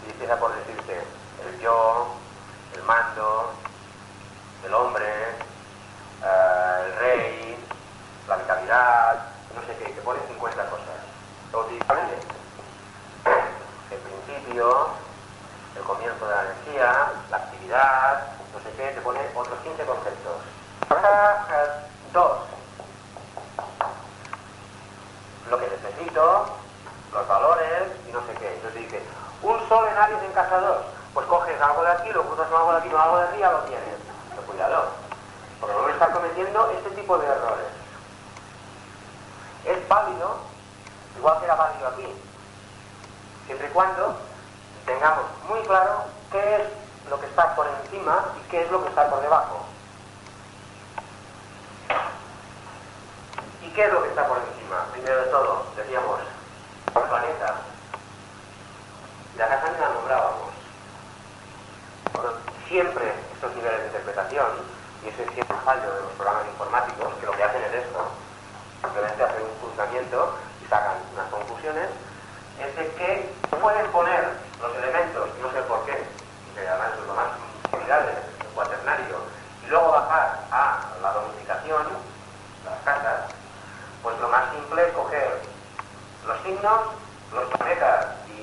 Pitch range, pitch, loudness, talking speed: 100-160 Hz, 110 Hz, -24 LUFS, 130 wpm